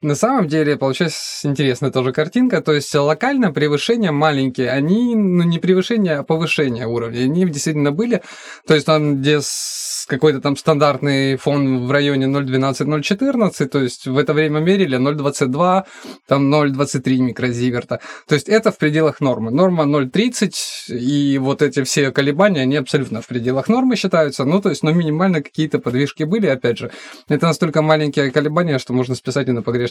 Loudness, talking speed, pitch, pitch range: -17 LUFS, 165 wpm, 150 Hz, 135-170 Hz